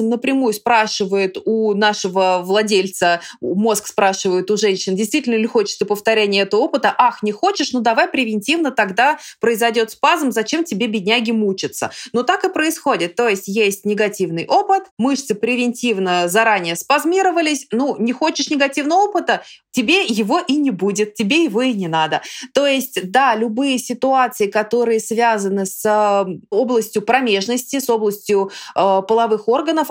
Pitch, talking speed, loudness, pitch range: 230 Hz, 140 wpm, -17 LUFS, 205-270 Hz